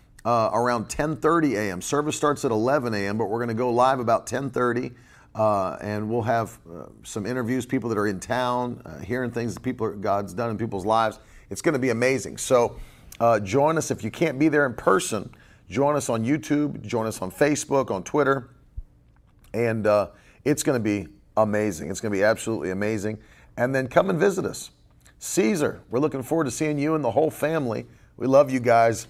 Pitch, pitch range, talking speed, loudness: 120 Hz, 110-140 Hz, 205 wpm, -24 LUFS